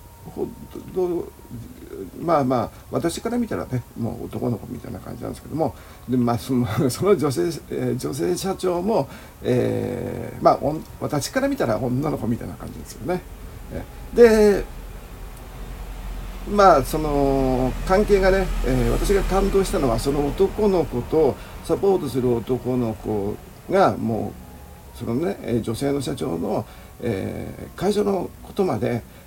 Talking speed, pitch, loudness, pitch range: 250 characters per minute, 135 Hz, -22 LUFS, 120-190 Hz